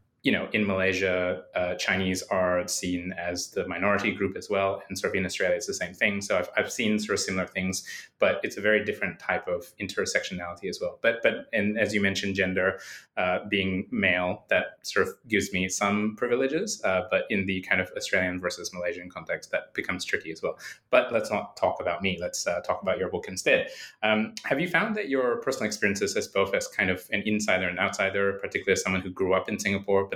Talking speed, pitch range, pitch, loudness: 225 wpm, 90-105 Hz, 95 Hz, -27 LUFS